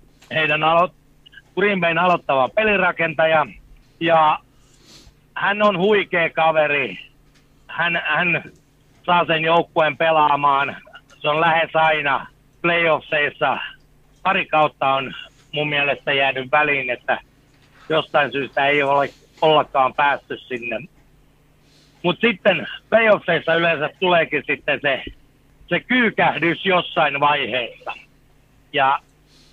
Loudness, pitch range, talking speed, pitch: -19 LUFS, 140-170 Hz, 100 wpm, 150 Hz